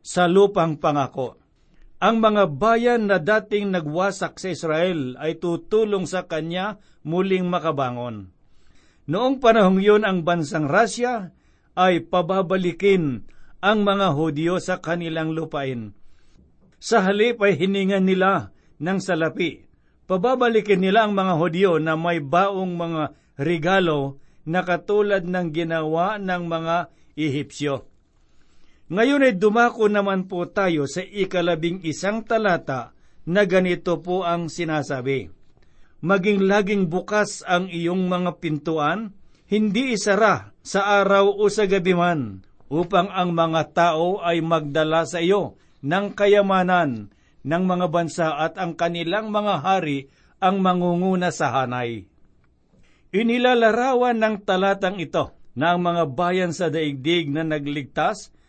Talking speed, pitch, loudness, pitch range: 125 wpm, 180 Hz, -21 LUFS, 160-195 Hz